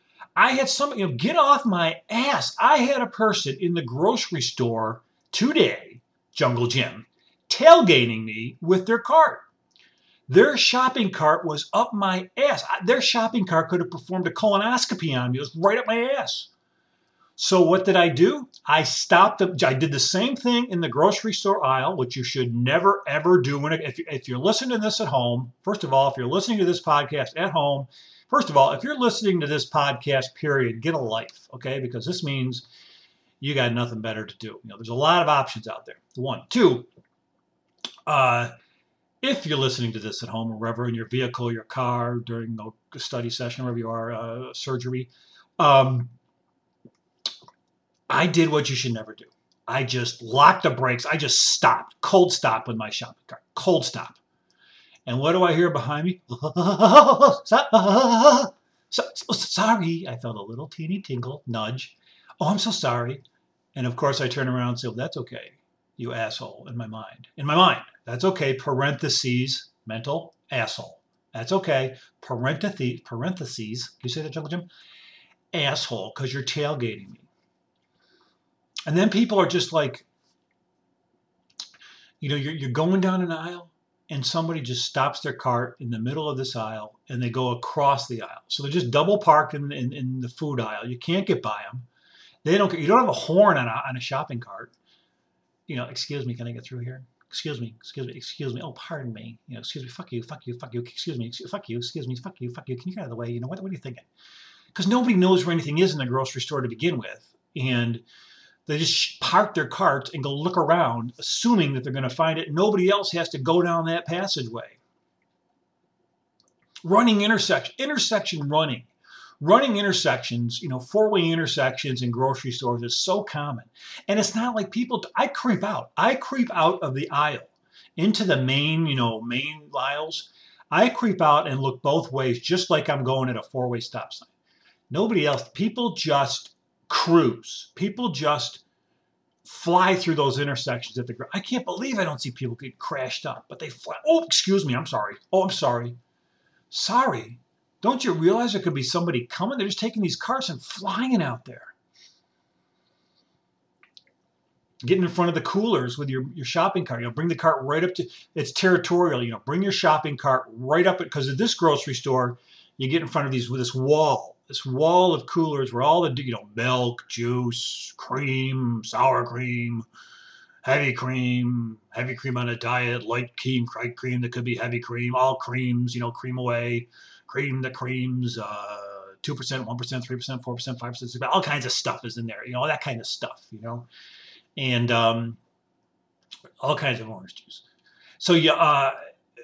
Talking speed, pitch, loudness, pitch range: 195 wpm, 140 Hz, -23 LUFS, 125-180 Hz